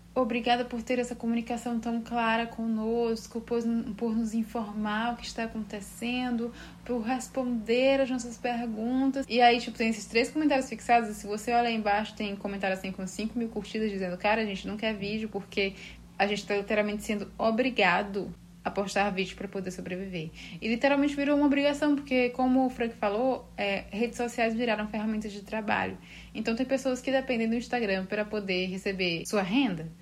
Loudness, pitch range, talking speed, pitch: -29 LUFS, 205-240 Hz, 180 wpm, 225 Hz